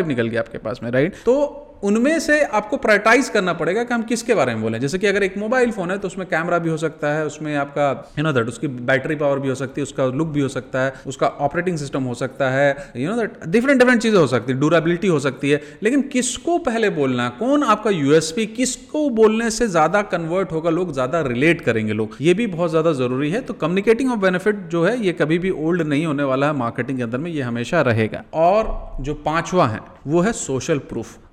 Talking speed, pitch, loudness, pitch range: 235 wpm, 160 Hz, -19 LUFS, 135-210 Hz